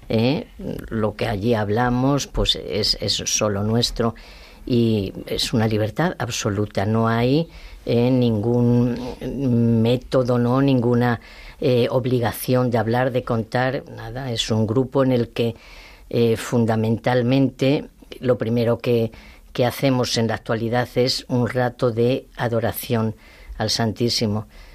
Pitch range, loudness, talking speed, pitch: 115-125 Hz, -21 LUFS, 125 wpm, 120 Hz